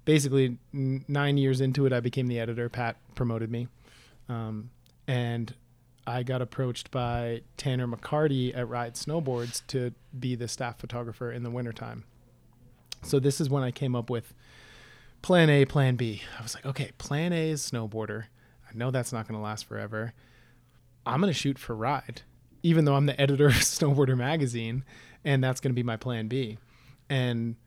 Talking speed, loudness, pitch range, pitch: 180 wpm, -29 LUFS, 120-135 Hz, 125 Hz